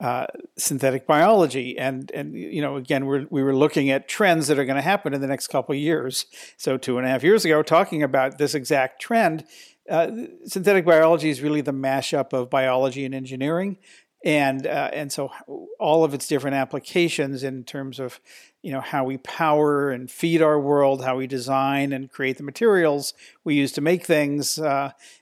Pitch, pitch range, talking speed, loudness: 140 Hz, 135-155 Hz, 195 wpm, -22 LUFS